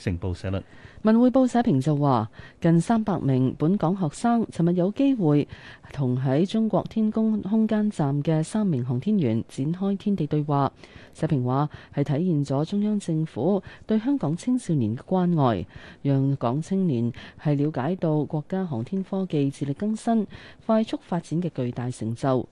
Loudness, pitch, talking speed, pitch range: -25 LUFS, 155 Hz, 245 characters per minute, 135-200 Hz